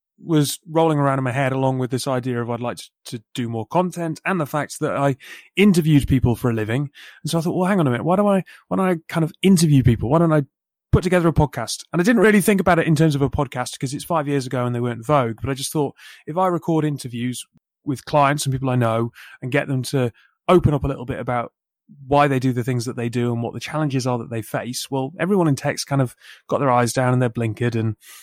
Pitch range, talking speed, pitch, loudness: 125-160 Hz, 275 wpm, 140 Hz, -20 LUFS